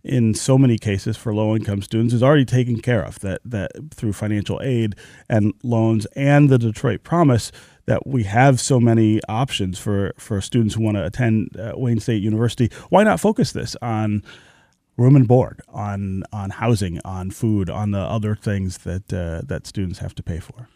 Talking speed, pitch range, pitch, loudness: 185 wpm, 100-125 Hz, 110 Hz, -20 LUFS